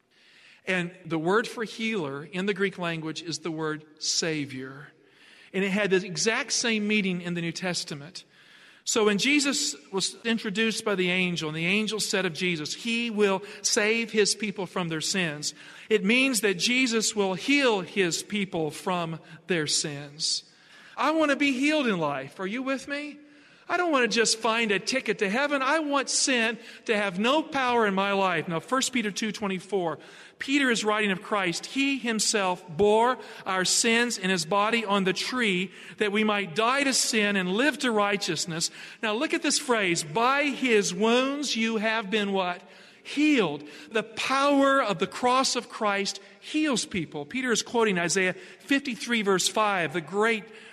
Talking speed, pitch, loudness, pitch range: 175 wpm, 210 Hz, -26 LUFS, 185-235 Hz